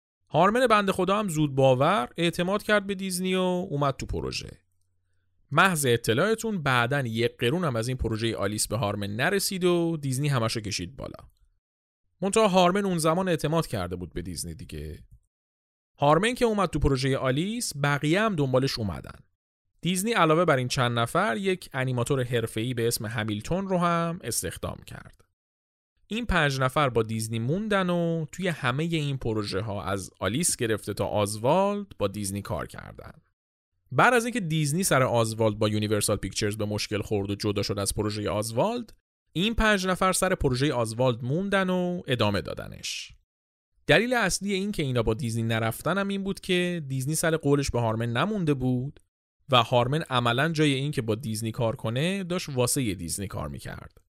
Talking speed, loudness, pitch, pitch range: 165 wpm, -26 LUFS, 130 Hz, 105-175 Hz